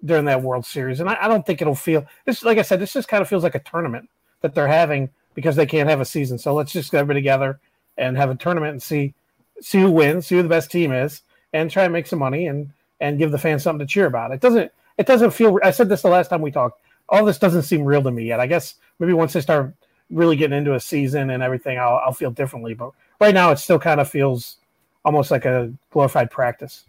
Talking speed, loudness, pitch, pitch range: 265 wpm, -19 LUFS, 155 Hz, 135-175 Hz